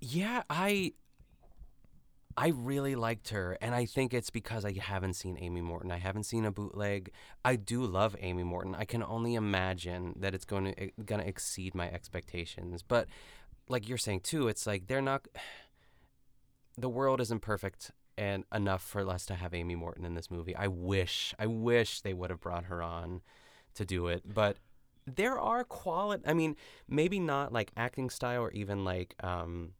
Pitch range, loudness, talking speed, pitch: 90-125 Hz, -35 LUFS, 185 wpm, 105 Hz